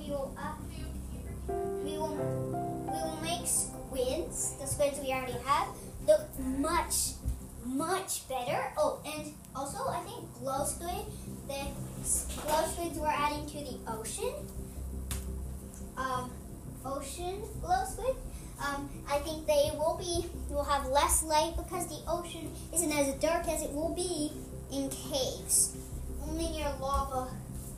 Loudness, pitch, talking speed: -33 LUFS, 265 Hz, 135 wpm